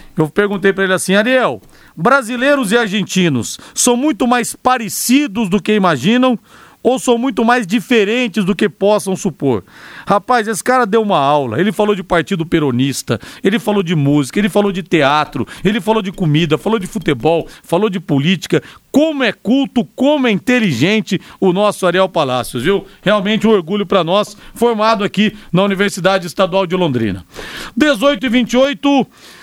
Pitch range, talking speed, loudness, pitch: 180-235 Hz, 165 wpm, -14 LUFS, 205 Hz